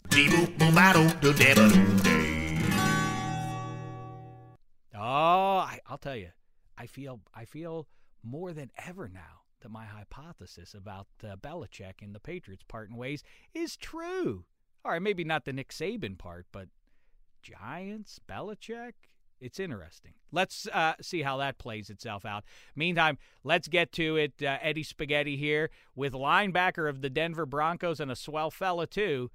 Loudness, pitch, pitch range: -27 LUFS, 140 Hz, 110-165 Hz